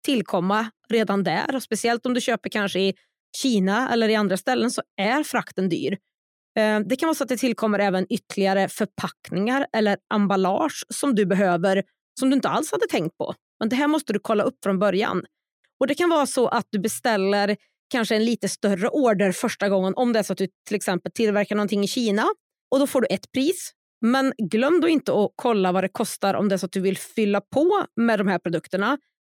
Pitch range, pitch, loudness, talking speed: 195-255 Hz, 215 Hz, -23 LUFS, 215 wpm